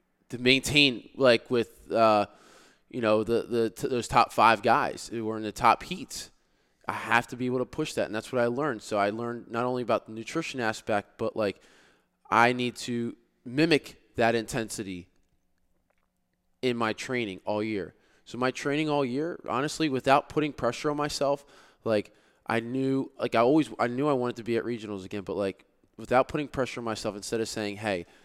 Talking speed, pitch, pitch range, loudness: 195 wpm, 120 Hz, 110-135 Hz, -28 LUFS